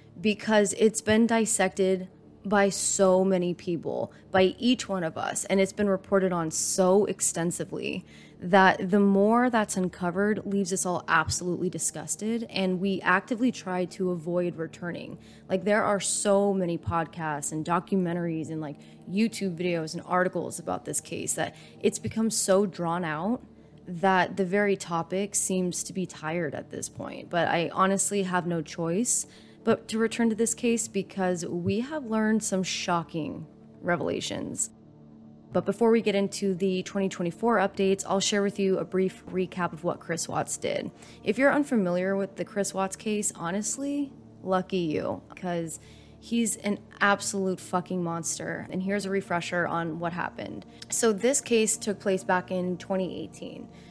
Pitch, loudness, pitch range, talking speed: 190 Hz, -27 LUFS, 175-205 Hz, 160 wpm